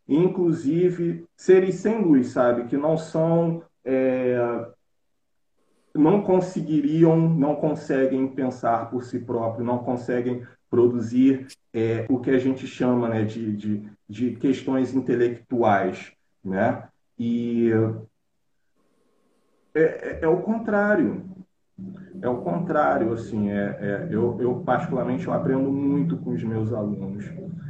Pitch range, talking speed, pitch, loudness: 120-165 Hz, 120 wpm, 130 Hz, -23 LUFS